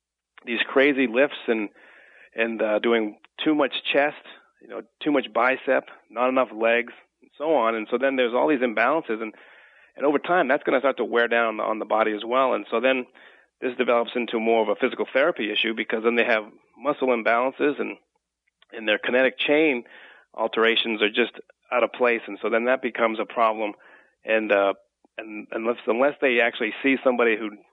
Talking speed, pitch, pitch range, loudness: 195 wpm, 115 Hz, 110-125 Hz, -23 LUFS